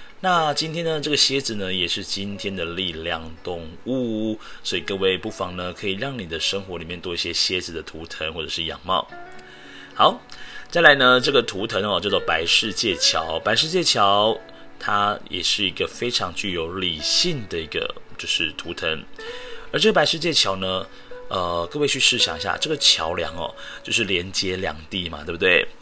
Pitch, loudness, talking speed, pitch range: 105 Hz, -21 LUFS, 265 characters per minute, 90-150 Hz